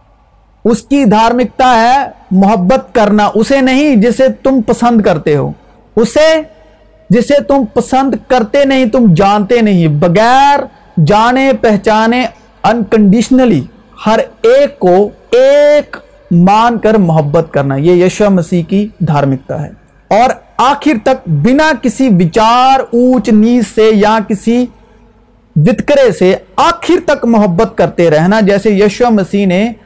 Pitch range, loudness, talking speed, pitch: 200-260 Hz, -9 LUFS, 125 wpm, 225 Hz